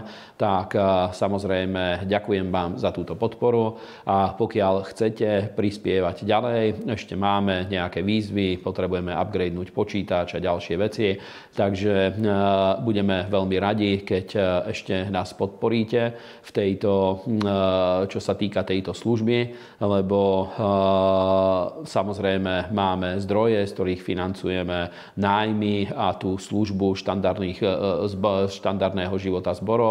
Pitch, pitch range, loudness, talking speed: 95 Hz, 95-105 Hz, -24 LUFS, 100 wpm